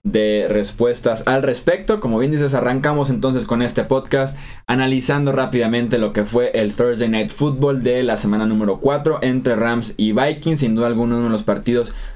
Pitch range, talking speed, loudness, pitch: 115-135 Hz, 180 wpm, -18 LUFS, 125 Hz